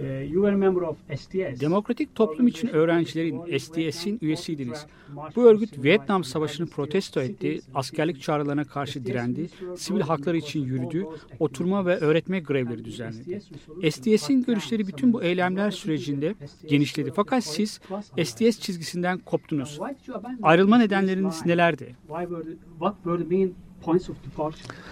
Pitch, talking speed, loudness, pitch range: 170 Hz, 95 wpm, -25 LUFS, 150-195 Hz